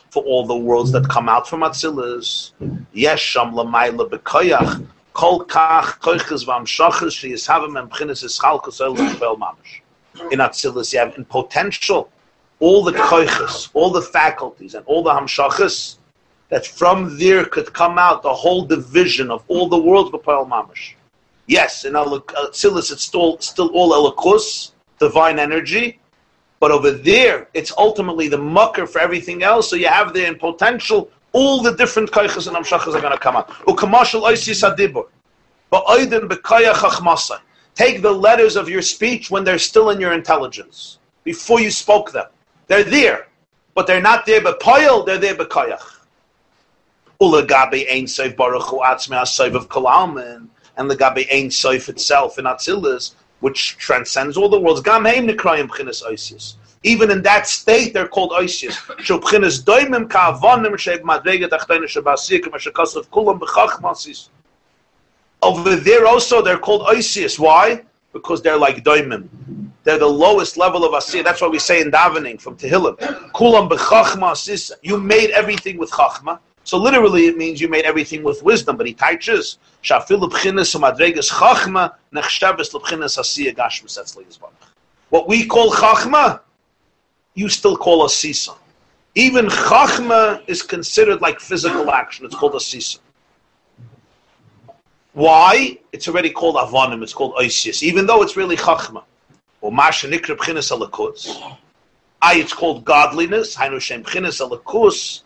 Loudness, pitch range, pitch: -15 LUFS, 160-255 Hz, 195 Hz